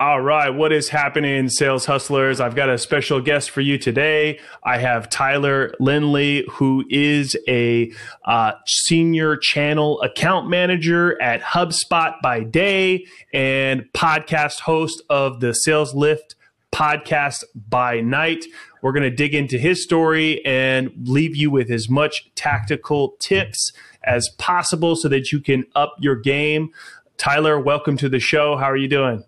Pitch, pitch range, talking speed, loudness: 145 Hz, 135-155 Hz, 150 wpm, -18 LUFS